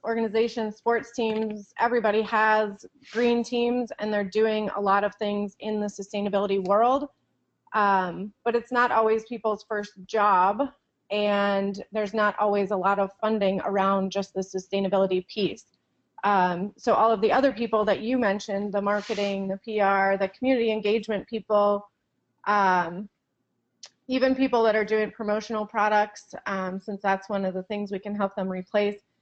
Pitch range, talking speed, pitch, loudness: 200-225 Hz, 160 wpm, 210 Hz, -25 LUFS